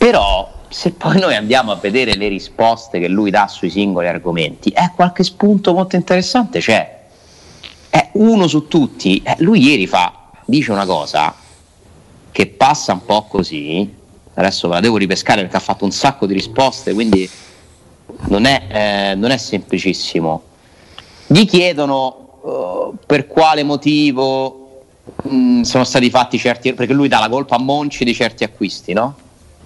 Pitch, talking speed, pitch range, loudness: 120 Hz, 160 wpm, 95-150 Hz, -14 LUFS